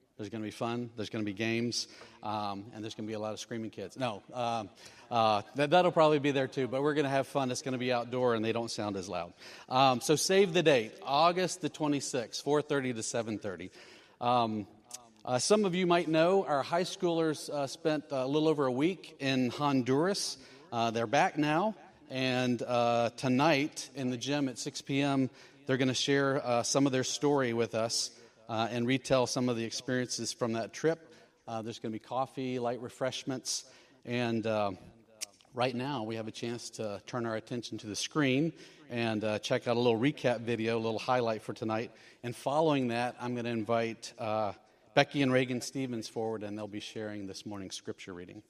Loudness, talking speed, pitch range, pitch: -32 LUFS, 210 wpm, 115-140 Hz, 125 Hz